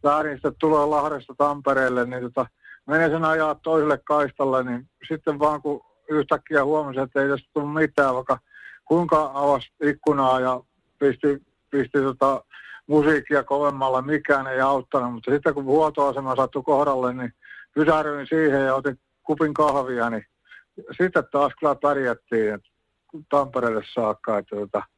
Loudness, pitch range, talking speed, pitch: -23 LUFS, 130-150 Hz, 140 wpm, 140 Hz